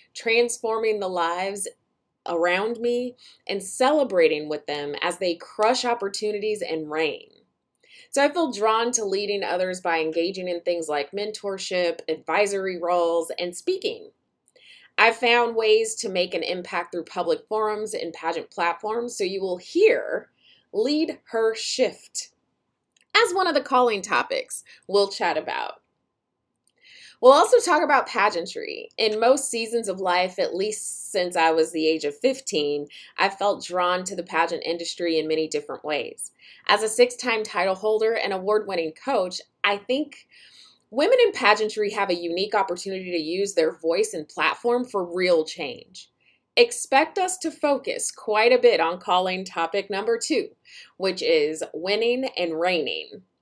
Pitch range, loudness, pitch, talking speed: 180-275 Hz, -23 LUFS, 215 Hz, 150 wpm